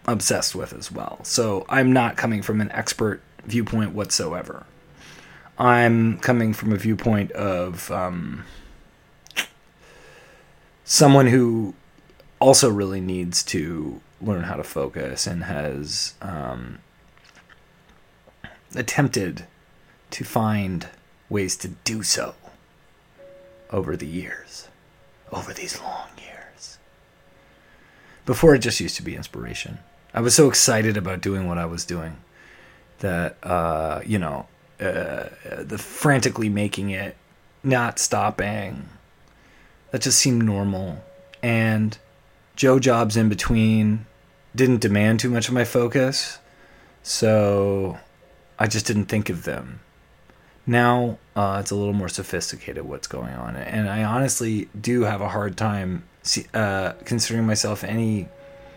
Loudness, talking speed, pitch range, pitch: -22 LUFS, 125 wpm, 95-120 Hz, 110 Hz